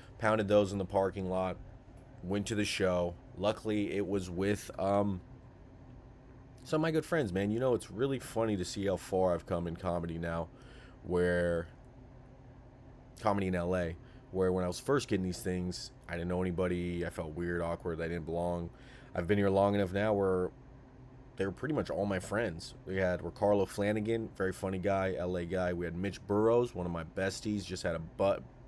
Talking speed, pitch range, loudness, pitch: 195 wpm, 90-120 Hz, -34 LUFS, 100 Hz